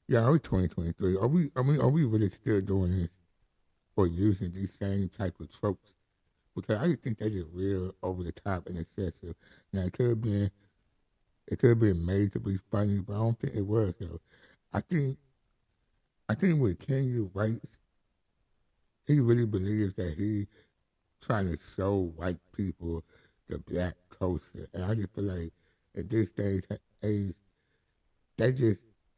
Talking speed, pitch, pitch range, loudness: 175 wpm, 100 Hz, 90-110 Hz, -31 LUFS